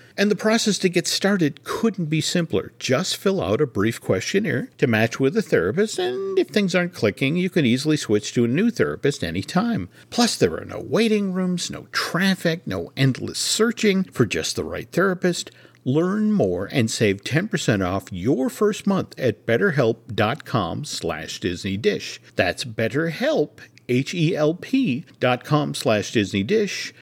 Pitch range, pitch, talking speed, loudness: 125-200 Hz, 165 Hz, 150 wpm, -22 LUFS